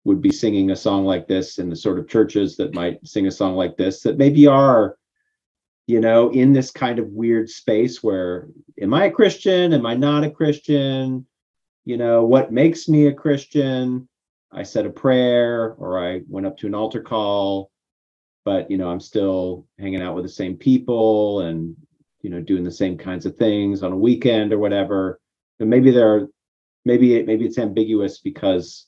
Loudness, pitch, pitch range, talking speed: -19 LUFS, 115 Hz, 95-135 Hz, 195 wpm